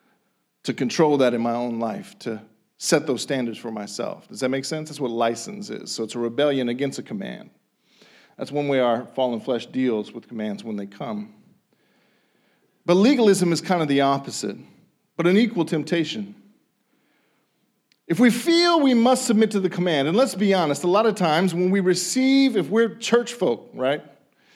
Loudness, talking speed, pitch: -22 LUFS, 185 wpm, 160 Hz